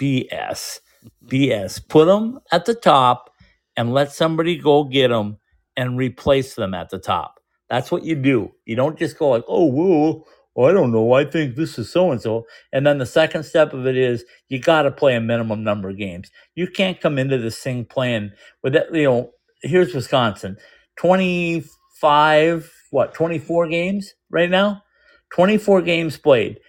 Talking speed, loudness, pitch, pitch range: 175 wpm, -19 LUFS, 150 Hz, 125-175 Hz